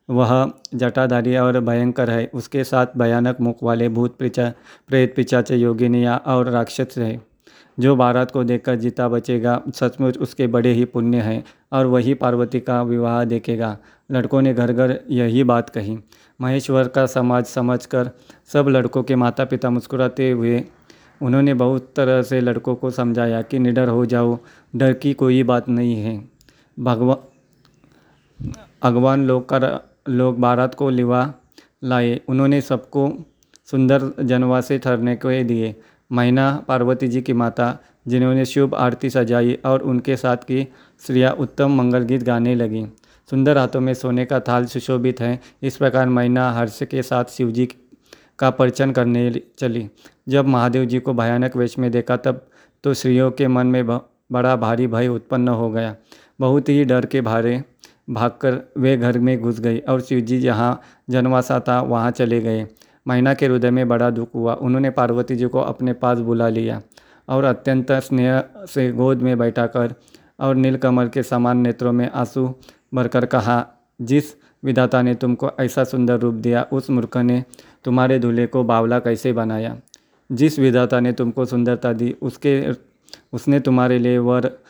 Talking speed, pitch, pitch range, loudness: 160 wpm, 125 Hz, 120-130 Hz, -19 LUFS